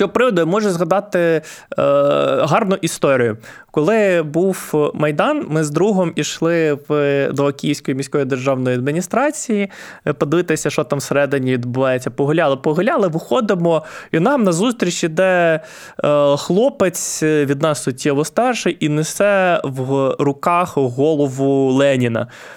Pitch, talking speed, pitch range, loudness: 155 Hz, 110 wpm, 140-180 Hz, -17 LUFS